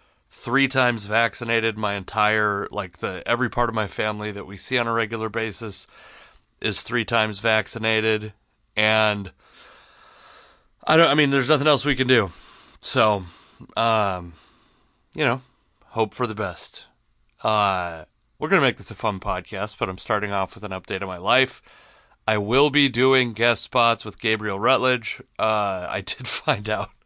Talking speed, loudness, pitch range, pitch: 165 wpm, -22 LUFS, 105-120 Hz, 110 Hz